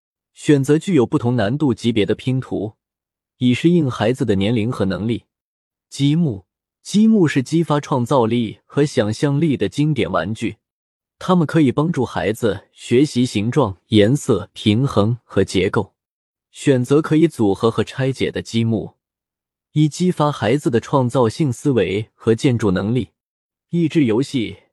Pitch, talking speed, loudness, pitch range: 130 Hz, 230 characters per minute, -18 LUFS, 110-150 Hz